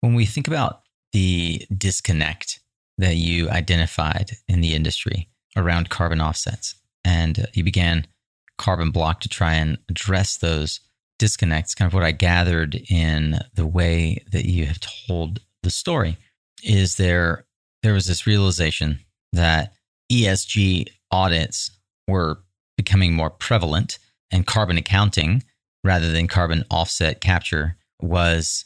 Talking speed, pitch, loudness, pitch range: 130 wpm, 90 Hz, -21 LUFS, 85-105 Hz